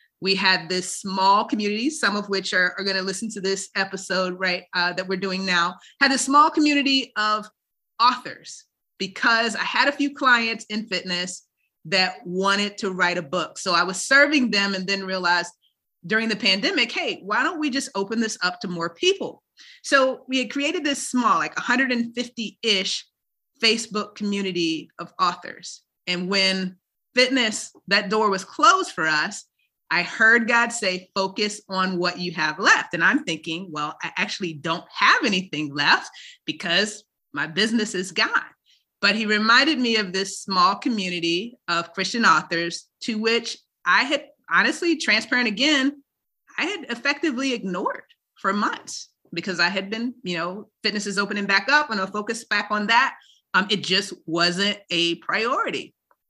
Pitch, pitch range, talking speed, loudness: 205 Hz, 185-245 Hz, 165 wpm, -22 LUFS